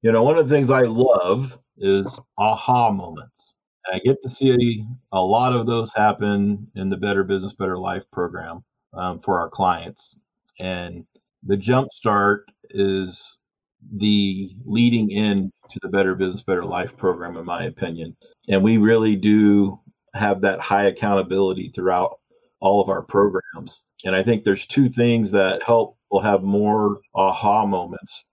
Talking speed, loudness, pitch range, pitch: 160 wpm, -20 LUFS, 95-115 Hz, 100 Hz